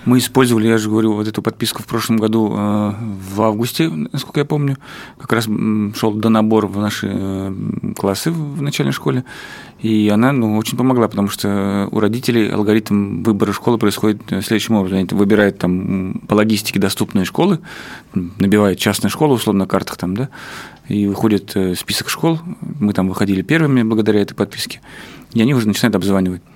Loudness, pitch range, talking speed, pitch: -17 LUFS, 100-120 Hz, 165 wpm, 110 Hz